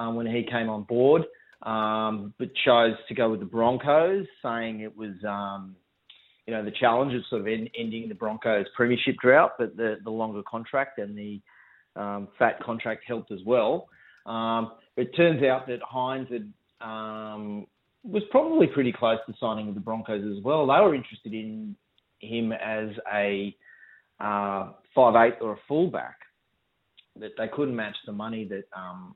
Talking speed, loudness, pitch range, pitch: 170 wpm, -26 LUFS, 105-125 Hz, 110 Hz